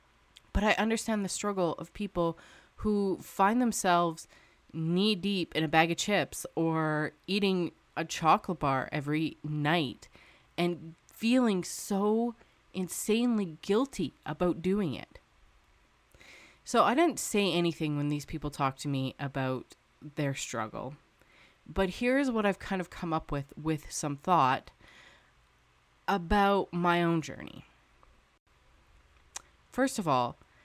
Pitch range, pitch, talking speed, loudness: 150-200 Hz, 170 Hz, 130 wpm, -30 LUFS